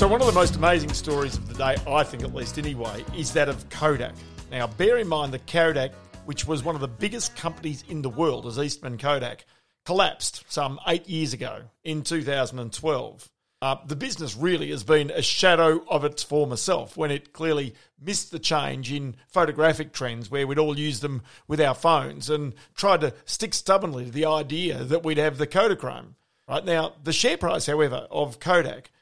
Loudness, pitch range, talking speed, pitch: -25 LUFS, 135-165 Hz, 195 wpm, 150 Hz